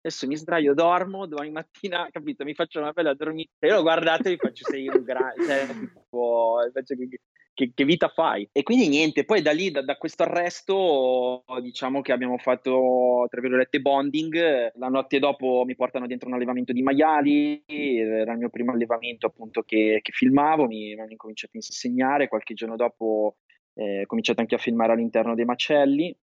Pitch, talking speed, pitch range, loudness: 135 Hz, 190 wpm, 120-155 Hz, -24 LUFS